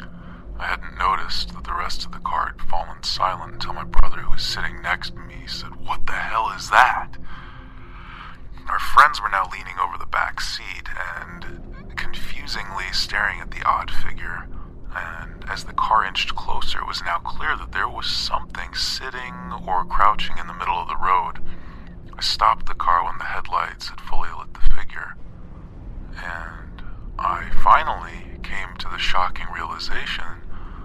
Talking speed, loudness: 165 wpm, -23 LUFS